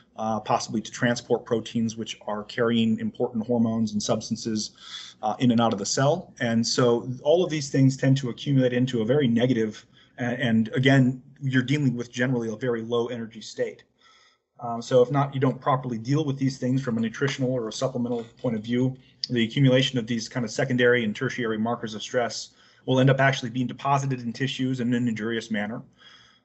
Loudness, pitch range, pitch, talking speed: -25 LUFS, 115-130 Hz, 120 Hz, 195 wpm